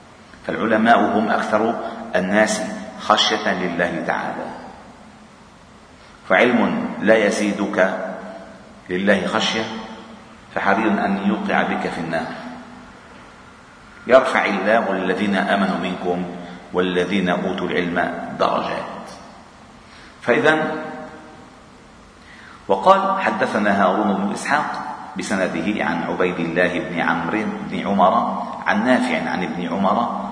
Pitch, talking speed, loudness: 95 Hz, 90 wpm, -19 LUFS